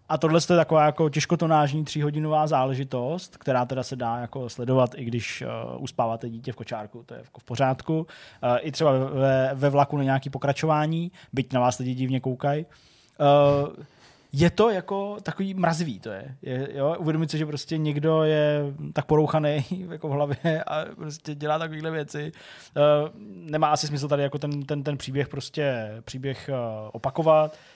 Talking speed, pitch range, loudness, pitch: 175 wpm, 130-155 Hz, -25 LUFS, 145 Hz